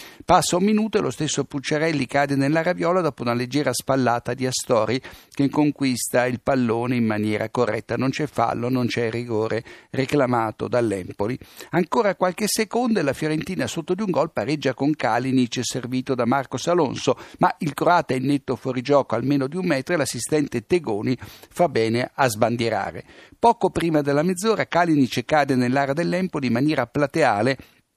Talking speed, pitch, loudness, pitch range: 165 wpm, 140 Hz, -22 LUFS, 125-165 Hz